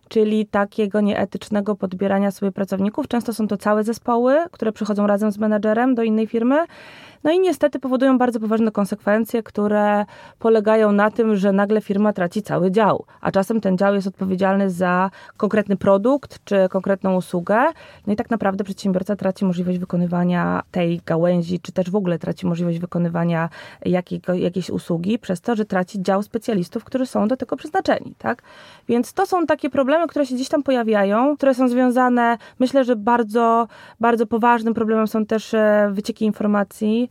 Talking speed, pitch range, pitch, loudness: 165 wpm, 195-235 Hz, 215 Hz, -20 LUFS